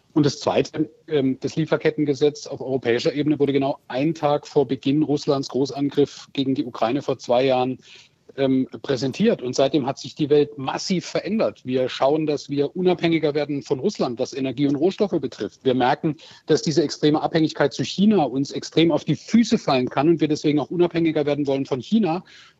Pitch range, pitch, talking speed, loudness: 135-155 Hz, 145 Hz, 180 wpm, -22 LUFS